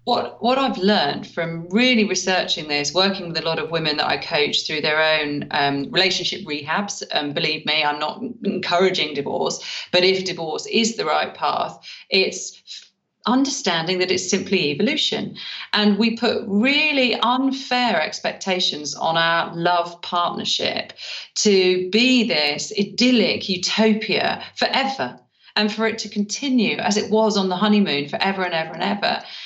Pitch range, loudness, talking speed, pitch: 170-220 Hz, -20 LUFS, 155 wpm, 195 Hz